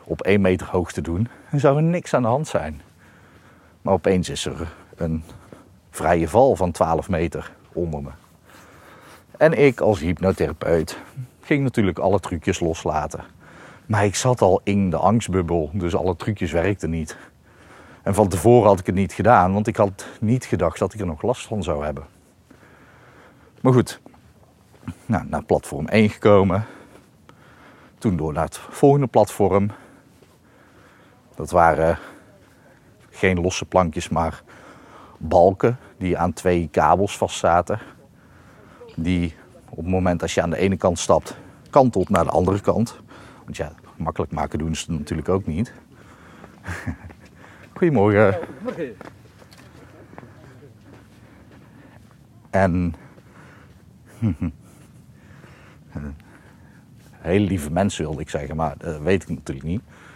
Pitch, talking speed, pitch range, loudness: 95 Hz, 130 wpm, 85-110 Hz, -21 LUFS